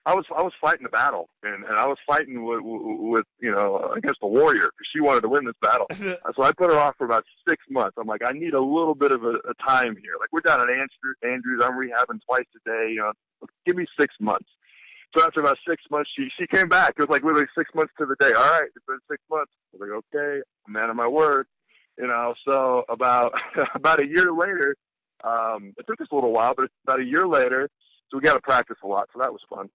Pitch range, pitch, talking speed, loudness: 120-160 Hz, 135 Hz, 255 wpm, -22 LUFS